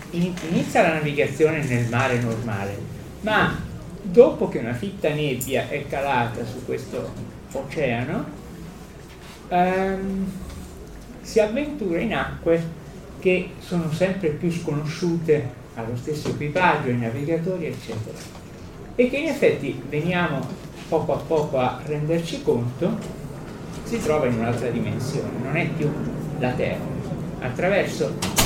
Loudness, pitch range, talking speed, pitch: -24 LUFS, 125-180 Hz, 115 wpm, 155 Hz